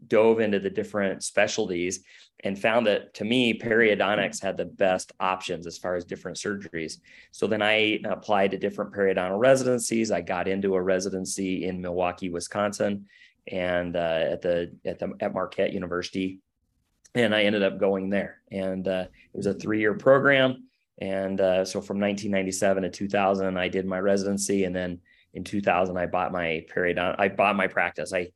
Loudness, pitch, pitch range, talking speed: -26 LUFS, 95 Hz, 90-100 Hz, 175 wpm